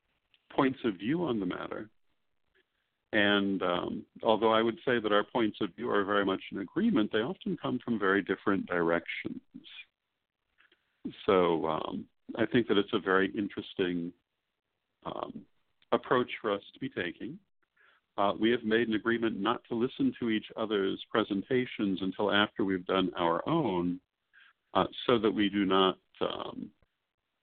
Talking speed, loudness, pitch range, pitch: 155 wpm, -30 LUFS, 95-115 Hz, 105 Hz